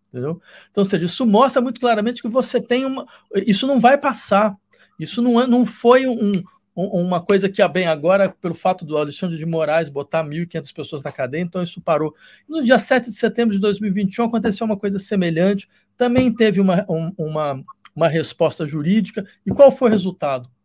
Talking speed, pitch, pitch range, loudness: 195 wpm, 195 Hz, 165-235 Hz, -19 LUFS